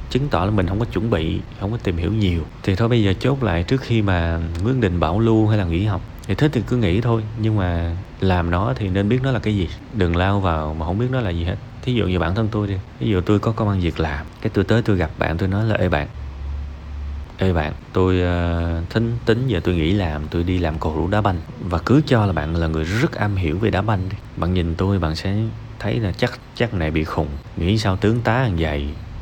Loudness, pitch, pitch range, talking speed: -21 LUFS, 95 Hz, 85-110 Hz, 270 wpm